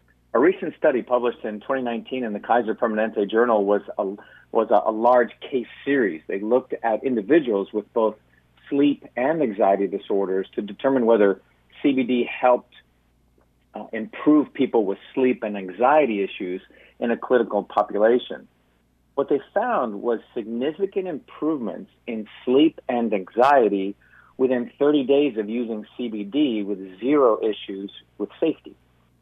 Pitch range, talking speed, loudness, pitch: 95-125 Hz, 140 wpm, -22 LUFS, 110 Hz